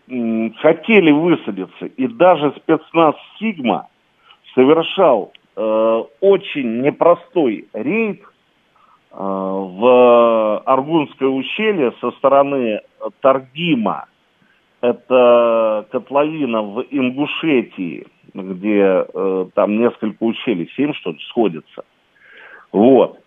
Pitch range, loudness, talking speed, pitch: 110-155 Hz, -16 LUFS, 80 wpm, 130 Hz